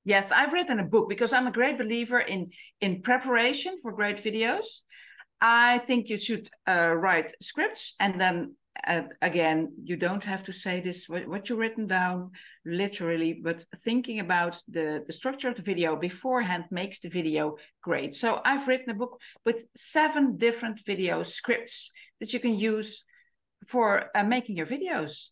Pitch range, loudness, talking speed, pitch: 180-245 Hz, -28 LUFS, 170 wpm, 215 Hz